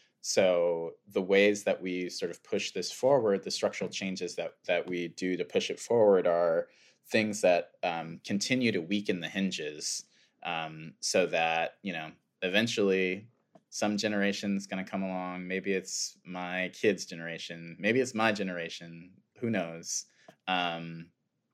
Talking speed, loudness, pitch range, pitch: 155 wpm, -31 LUFS, 85-105 Hz, 95 Hz